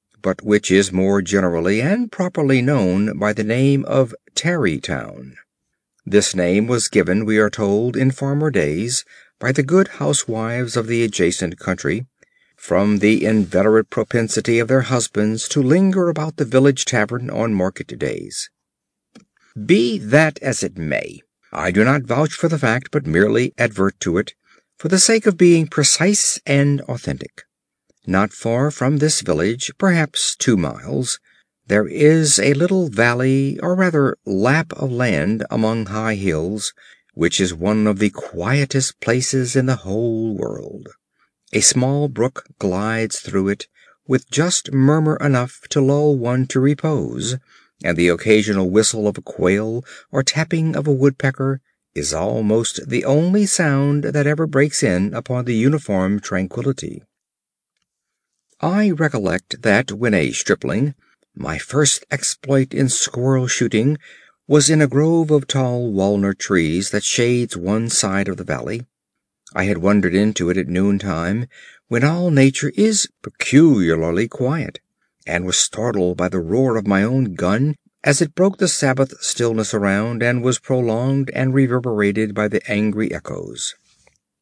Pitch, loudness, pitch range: 120 Hz, -18 LUFS, 105-145 Hz